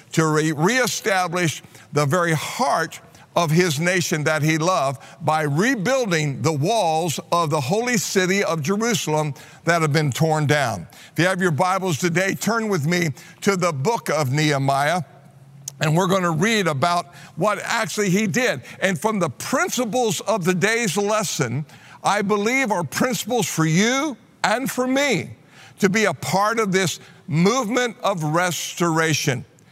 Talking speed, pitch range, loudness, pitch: 155 wpm, 155-205 Hz, -21 LUFS, 175 Hz